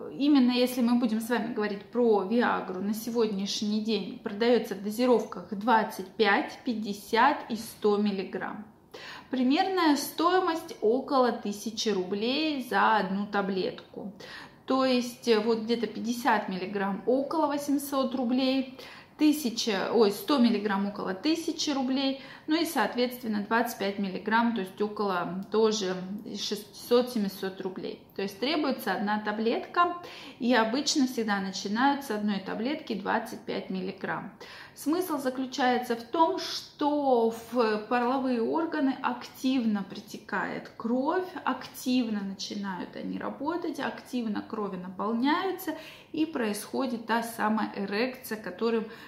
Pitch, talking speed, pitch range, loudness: 230 Hz, 115 wpm, 210-265 Hz, -29 LUFS